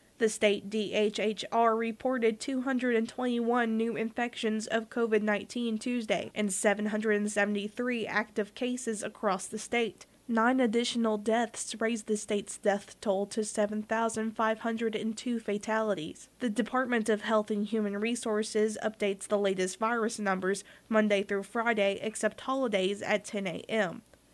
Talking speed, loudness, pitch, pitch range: 120 wpm, -30 LUFS, 220 Hz, 210-230 Hz